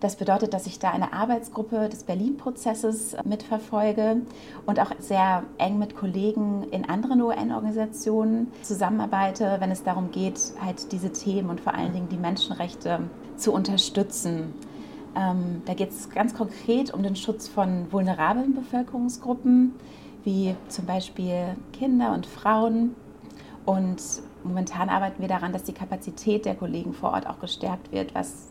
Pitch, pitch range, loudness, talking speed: 200 Hz, 185-225 Hz, -26 LUFS, 145 wpm